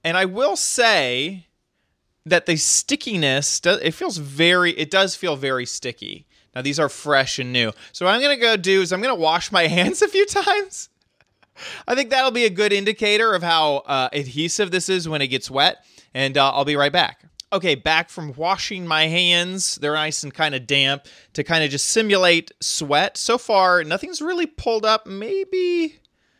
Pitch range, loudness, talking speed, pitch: 150-220 Hz, -19 LUFS, 195 wpm, 175 Hz